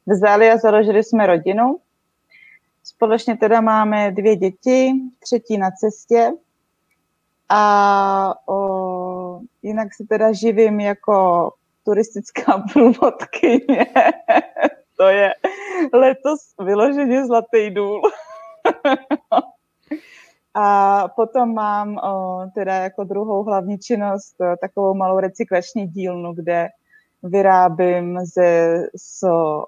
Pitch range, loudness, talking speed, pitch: 190-240 Hz, -17 LUFS, 95 wpm, 210 Hz